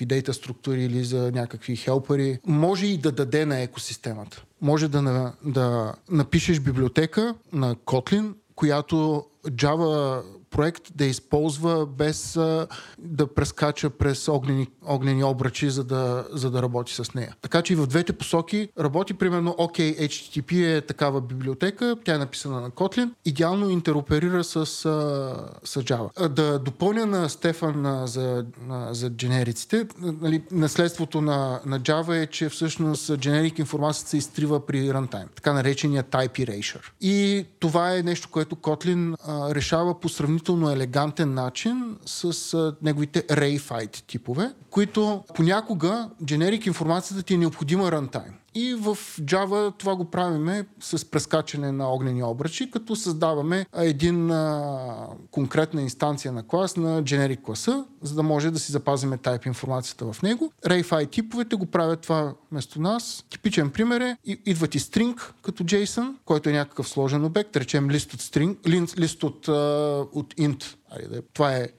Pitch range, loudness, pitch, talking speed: 135-175 Hz, -25 LUFS, 155 Hz, 150 wpm